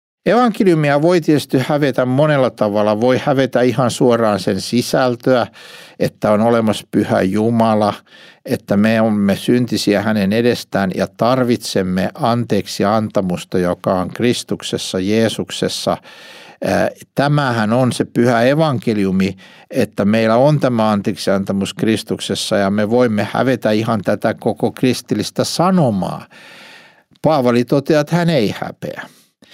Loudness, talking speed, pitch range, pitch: -16 LUFS, 115 wpm, 105-130 Hz, 115 Hz